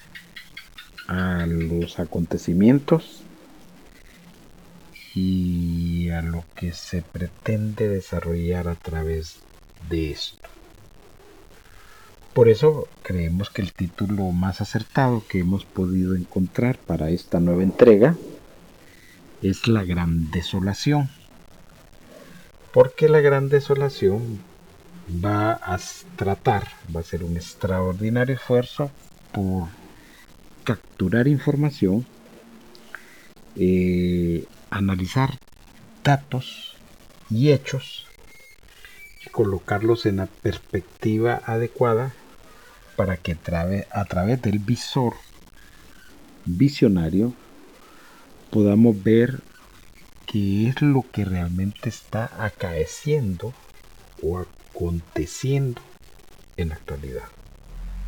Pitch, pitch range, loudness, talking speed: 100 Hz, 90-120 Hz, -23 LUFS, 85 wpm